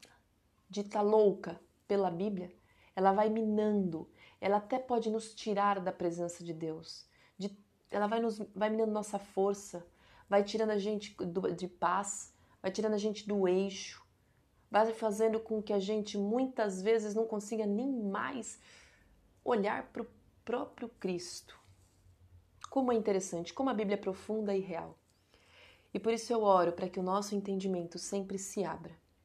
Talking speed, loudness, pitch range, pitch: 160 wpm, -34 LUFS, 180-215 Hz, 200 Hz